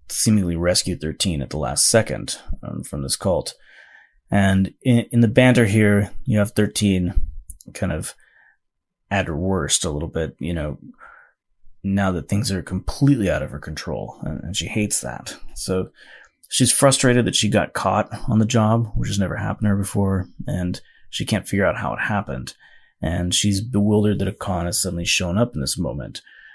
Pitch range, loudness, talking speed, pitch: 85-105 Hz, -21 LUFS, 185 wpm, 95 Hz